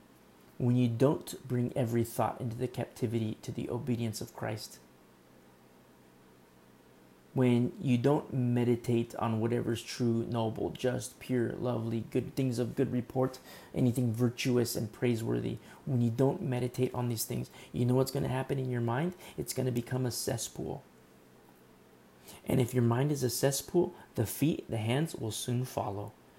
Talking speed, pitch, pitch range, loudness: 160 wpm, 120 Hz, 115-130 Hz, -32 LUFS